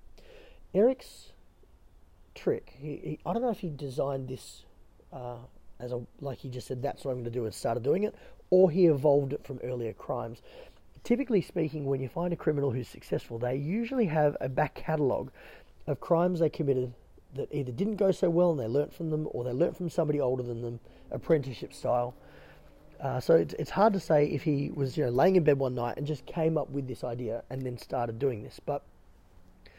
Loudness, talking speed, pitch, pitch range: -30 LUFS, 210 wpm, 140 Hz, 125-170 Hz